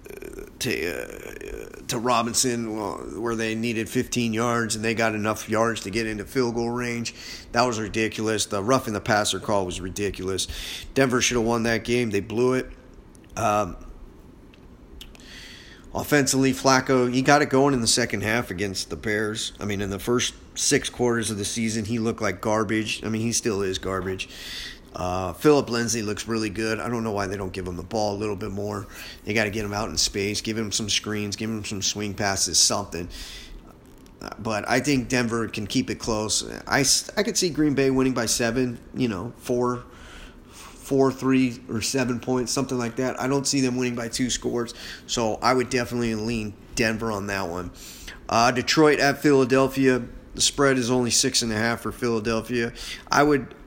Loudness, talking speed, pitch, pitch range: -24 LUFS, 190 wpm, 115 Hz, 105-125 Hz